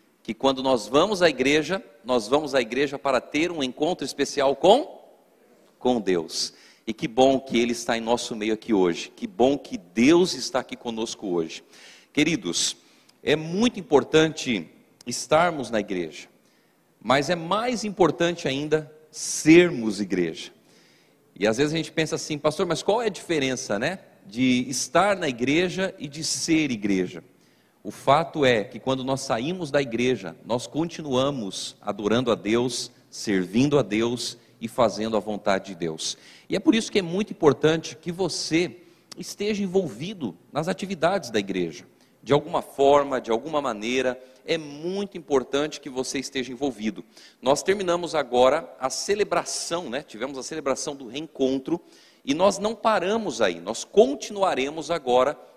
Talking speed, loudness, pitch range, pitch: 155 wpm, -24 LUFS, 125-170 Hz, 140 Hz